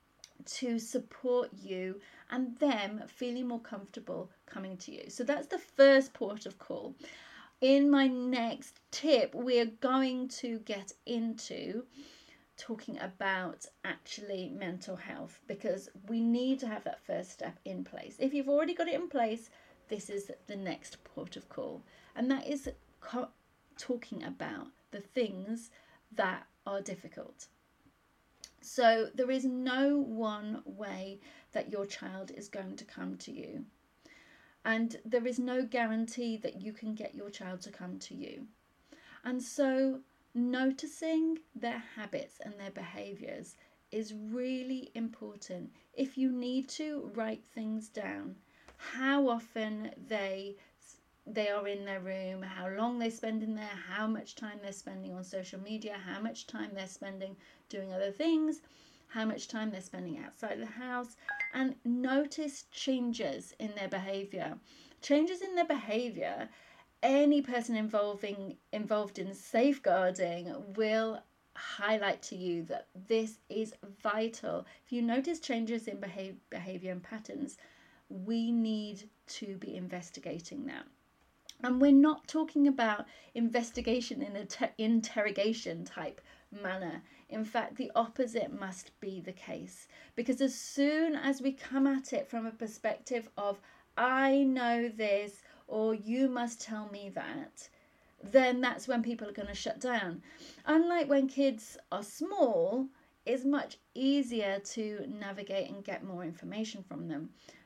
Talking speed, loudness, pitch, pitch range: 145 wpm, -35 LUFS, 230 Hz, 205-270 Hz